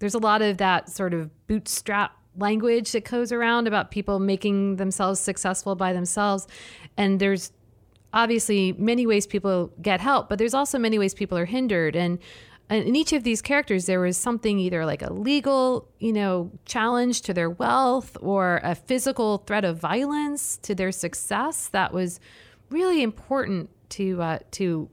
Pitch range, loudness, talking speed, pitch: 185-235 Hz, -24 LUFS, 170 wpm, 205 Hz